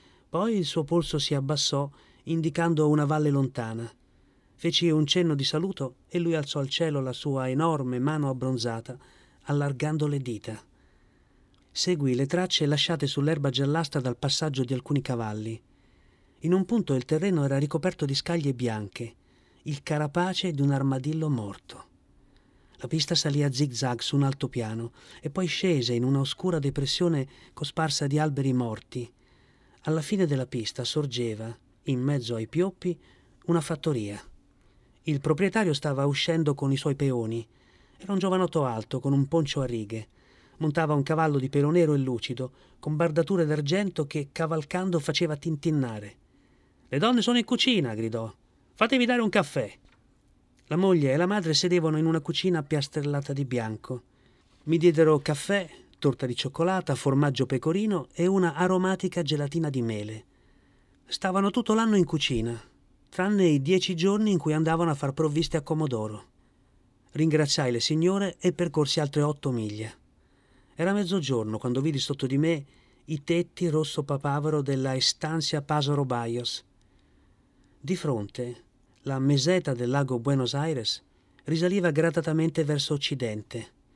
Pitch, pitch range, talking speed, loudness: 145 Hz, 130-165 Hz, 145 wpm, -27 LUFS